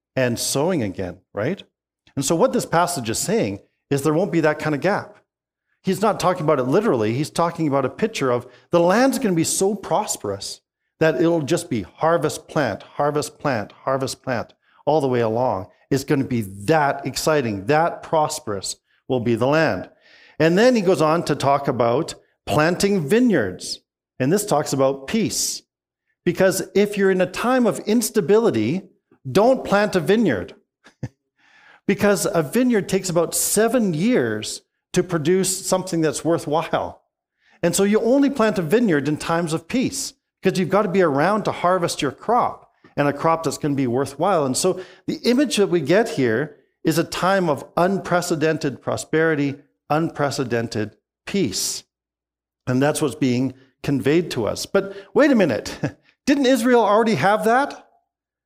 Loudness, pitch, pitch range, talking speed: -20 LUFS, 165 Hz, 140-195 Hz, 170 wpm